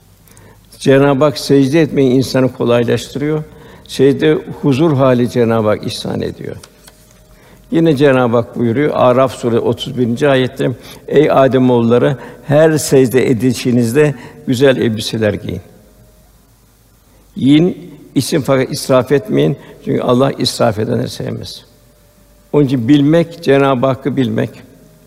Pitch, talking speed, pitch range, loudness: 130 Hz, 110 wpm, 120-145 Hz, -13 LUFS